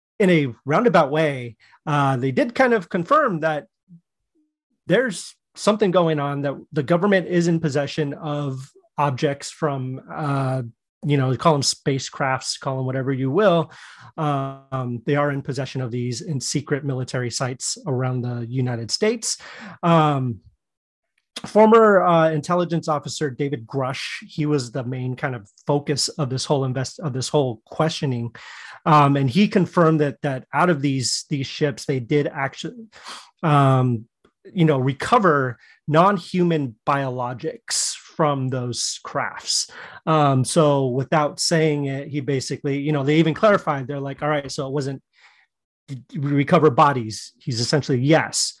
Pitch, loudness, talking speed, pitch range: 145 Hz, -21 LUFS, 150 wpm, 130-160 Hz